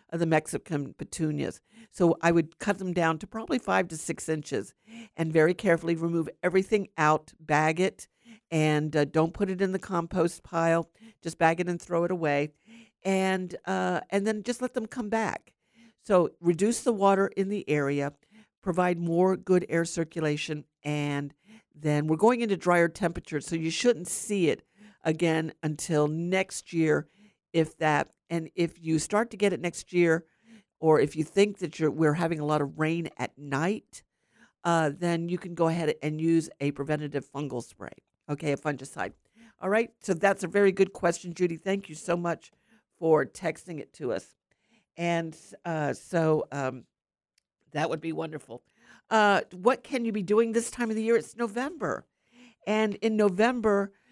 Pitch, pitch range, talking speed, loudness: 170 Hz, 155-205 Hz, 175 wpm, -28 LUFS